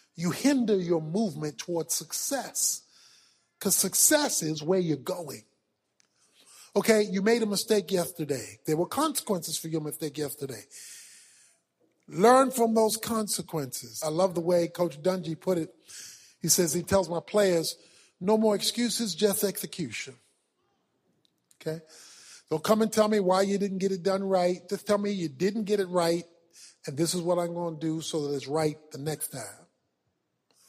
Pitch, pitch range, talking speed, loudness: 180 Hz, 160-205 Hz, 165 wpm, -27 LUFS